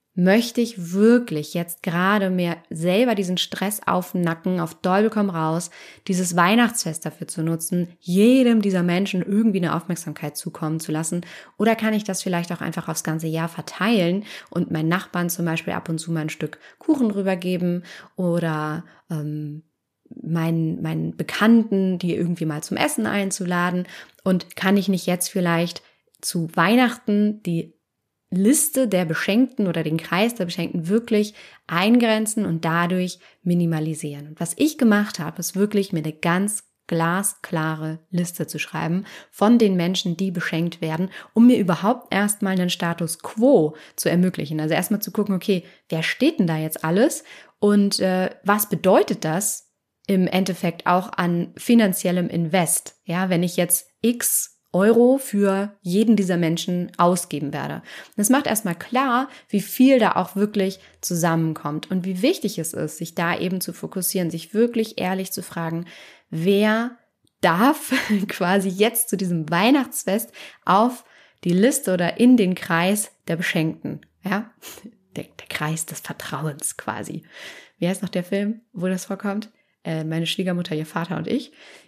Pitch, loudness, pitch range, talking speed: 185 Hz, -22 LUFS, 170-210 Hz, 155 wpm